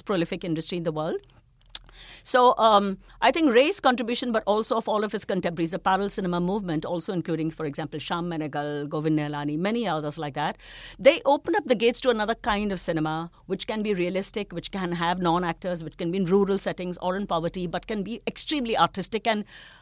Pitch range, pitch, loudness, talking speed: 165-215 Hz, 185 Hz, -26 LUFS, 205 wpm